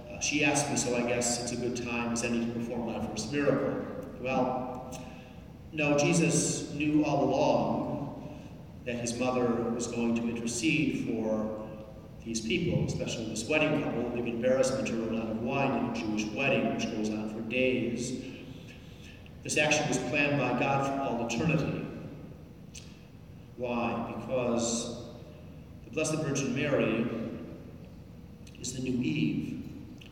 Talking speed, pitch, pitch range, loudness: 145 wpm, 120 Hz, 115-135 Hz, -30 LUFS